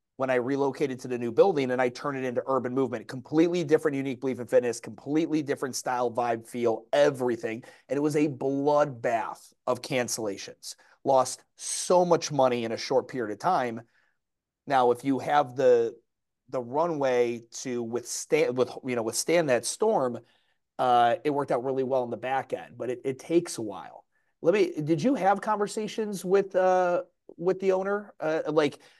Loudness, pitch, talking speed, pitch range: -27 LUFS, 140 Hz, 180 wpm, 125-175 Hz